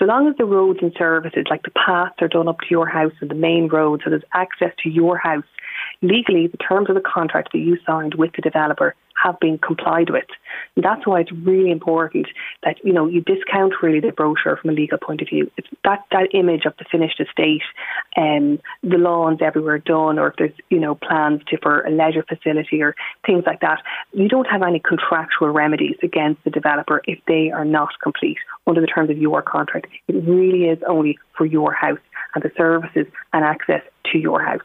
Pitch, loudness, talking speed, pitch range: 165 Hz, -18 LUFS, 215 wpm, 155-180 Hz